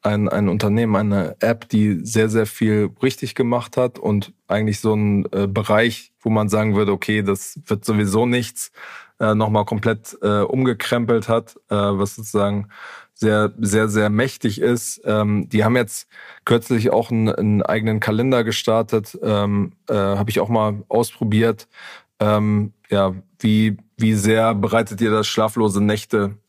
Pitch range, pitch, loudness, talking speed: 105-115 Hz, 110 Hz, -19 LUFS, 155 wpm